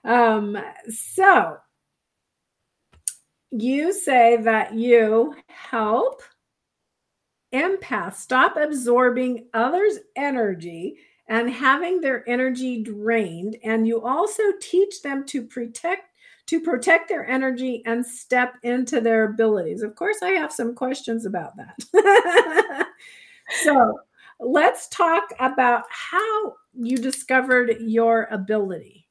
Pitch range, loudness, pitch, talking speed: 230-350 Hz, -21 LUFS, 255 Hz, 105 wpm